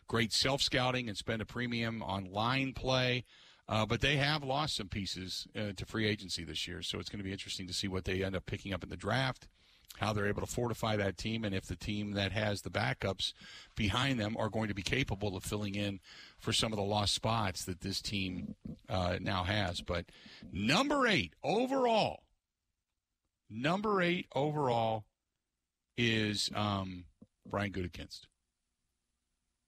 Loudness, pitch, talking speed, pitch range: -34 LUFS, 105 Hz, 180 wpm, 95-115 Hz